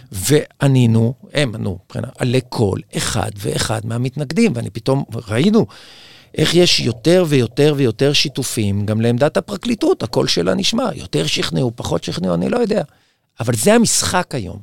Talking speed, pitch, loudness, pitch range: 145 wpm, 135 Hz, -17 LUFS, 115-160 Hz